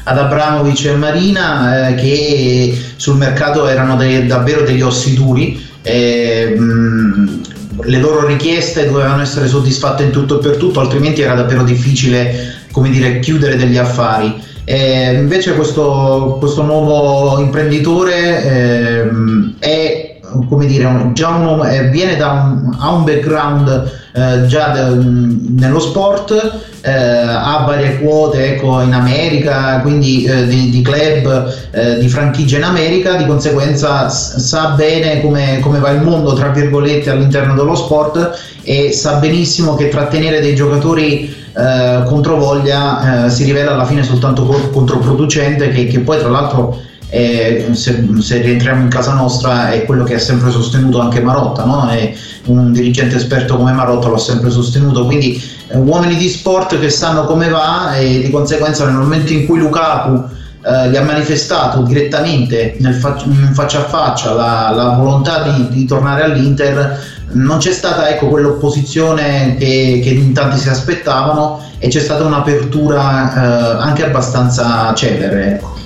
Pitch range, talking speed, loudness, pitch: 125-150 Hz, 145 wpm, -11 LUFS, 135 Hz